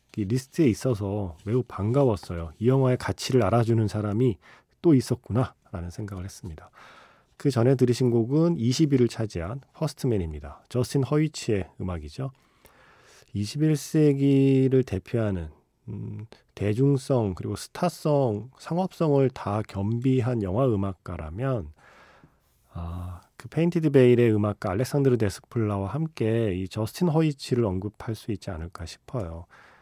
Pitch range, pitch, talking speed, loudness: 100-135 Hz, 115 Hz, 305 characters per minute, -25 LUFS